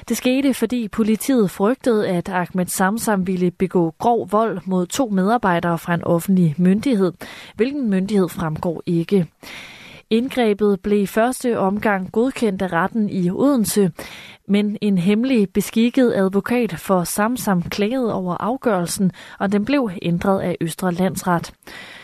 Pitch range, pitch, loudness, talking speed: 180-225 Hz, 200 Hz, -19 LUFS, 135 wpm